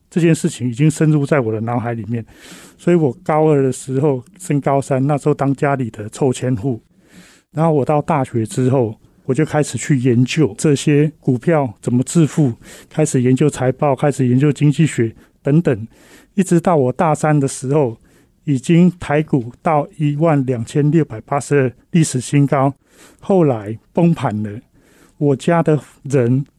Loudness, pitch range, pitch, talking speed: -17 LUFS, 125-155 Hz, 140 Hz, 250 characters per minute